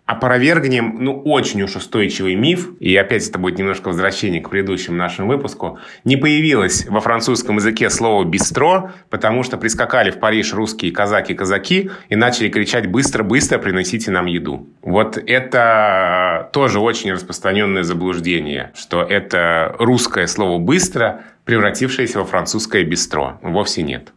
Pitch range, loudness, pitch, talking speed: 95-125 Hz, -16 LUFS, 110 Hz, 135 wpm